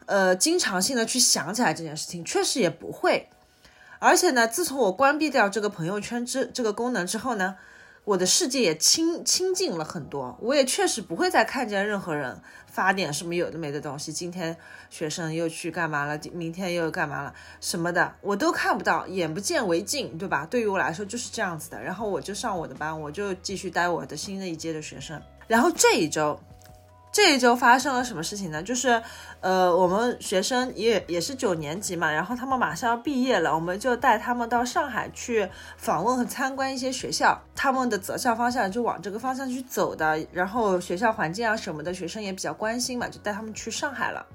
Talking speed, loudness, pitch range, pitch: 320 characters per minute, -25 LUFS, 170-250 Hz, 205 Hz